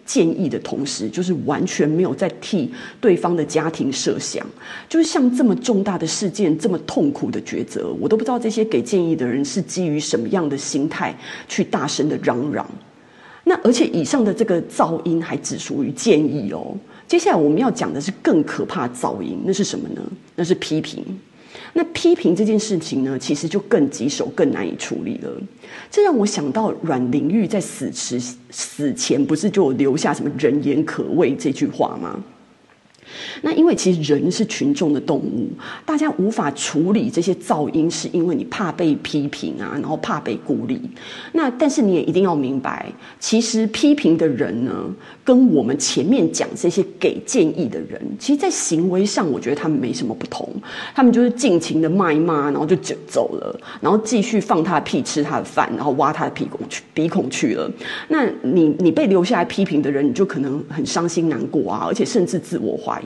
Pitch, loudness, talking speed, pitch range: 195 Hz, -19 LUFS, 290 characters per minute, 160-240 Hz